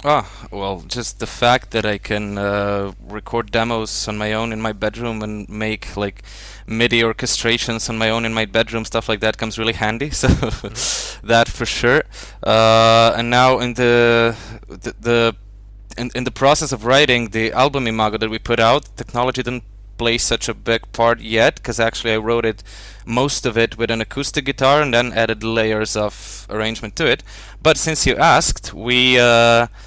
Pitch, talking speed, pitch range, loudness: 115 Hz, 185 wpm, 110-120 Hz, -17 LUFS